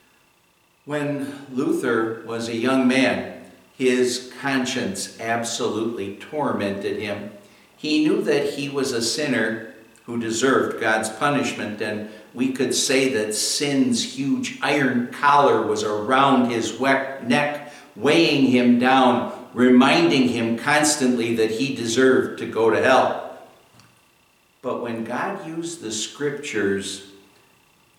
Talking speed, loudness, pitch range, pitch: 115 wpm, -21 LUFS, 115-145 Hz, 125 Hz